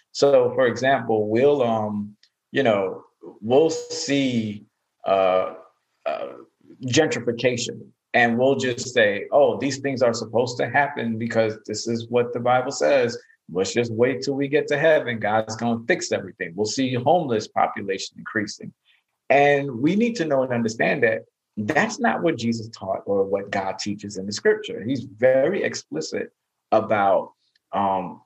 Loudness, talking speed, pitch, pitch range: -22 LUFS, 155 wpm, 125 Hz, 110-145 Hz